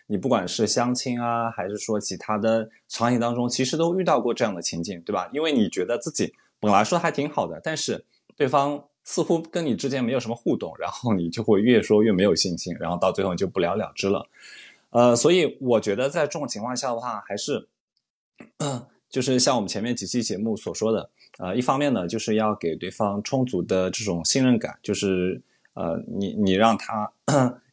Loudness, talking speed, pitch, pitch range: -24 LUFS, 305 characters per minute, 115 Hz, 100-135 Hz